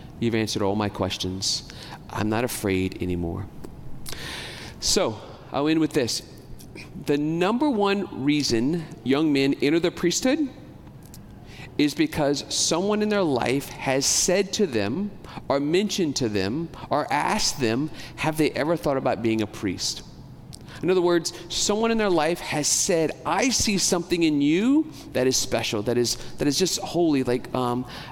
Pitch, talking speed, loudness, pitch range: 145 Hz, 155 wpm, -24 LUFS, 120-175 Hz